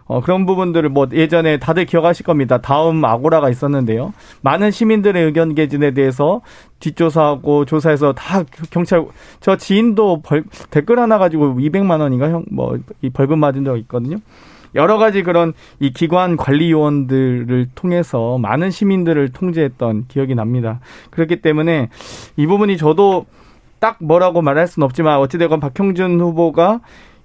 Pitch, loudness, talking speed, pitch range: 160 Hz, -15 LUFS, 335 characters per minute, 140-175 Hz